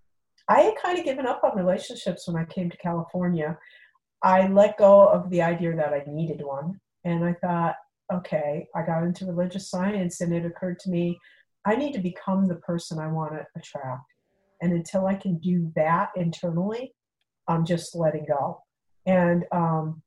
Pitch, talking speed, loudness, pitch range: 175 Hz, 180 wpm, -25 LUFS, 165-190 Hz